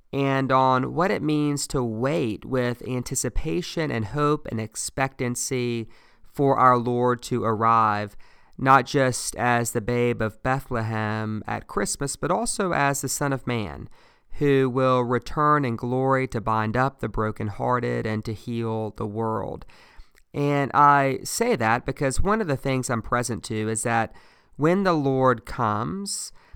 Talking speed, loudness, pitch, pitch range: 150 wpm, -24 LUFS, 125 Hz, 115-140 Hz